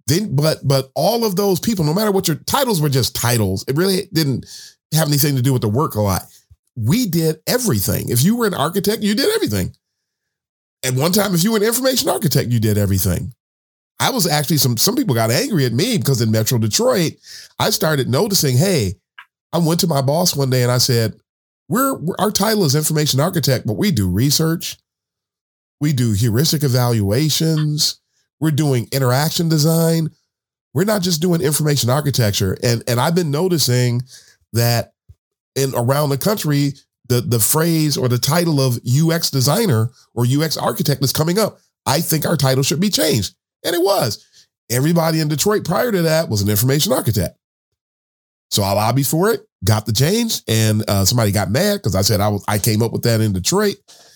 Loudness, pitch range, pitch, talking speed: -17 LUFS, 115-165 Hz, 140 Hz, 190 wpm